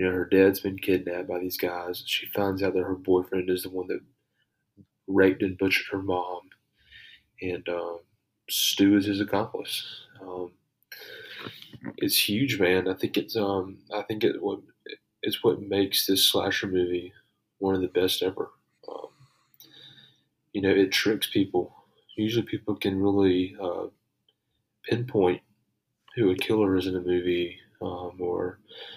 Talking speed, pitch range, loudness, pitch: 155 wpm, 90-95 Hz, -26 LUFS, 95 Hz